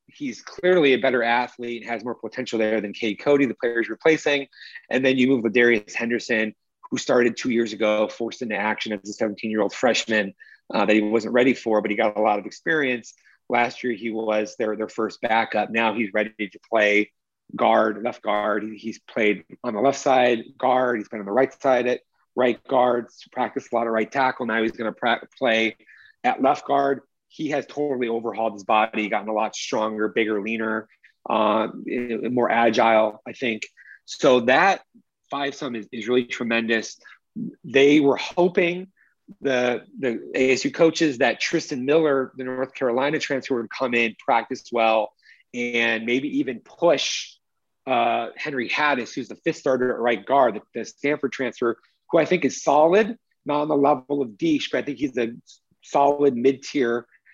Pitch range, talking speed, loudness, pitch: 110-135 Hz, 185 wpm, -22 LUFS, 120 Hz